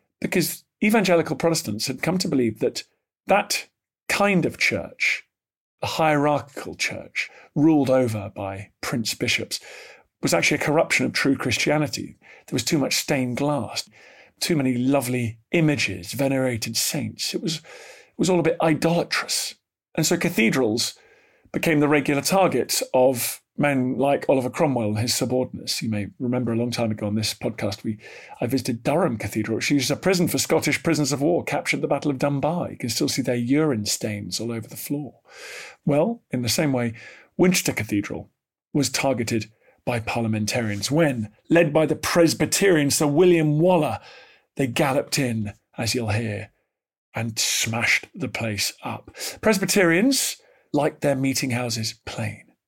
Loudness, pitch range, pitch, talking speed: -23 LUFS, 115-160 Hz, 135 Hz, 160 wpm